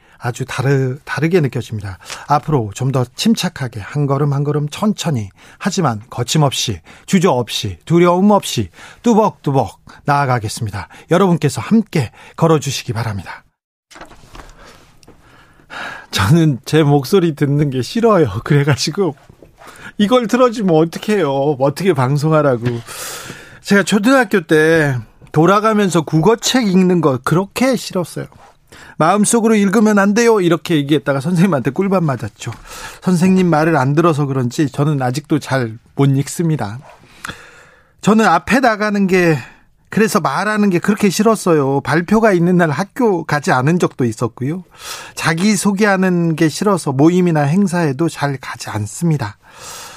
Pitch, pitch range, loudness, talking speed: 160 Hz, 135-195 Hz, -15 LUFS, 305 characters per minute